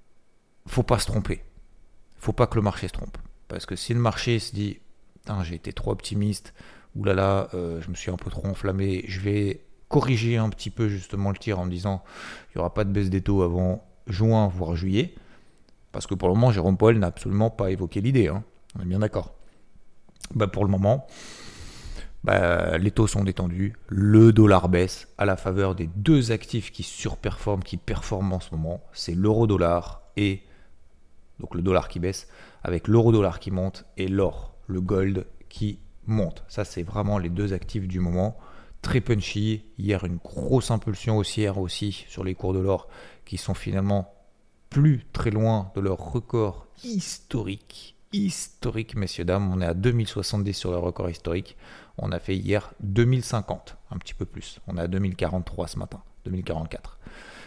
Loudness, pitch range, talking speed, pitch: -25 LUFS, 90-110 Hz, 185 wpm, 100 Hz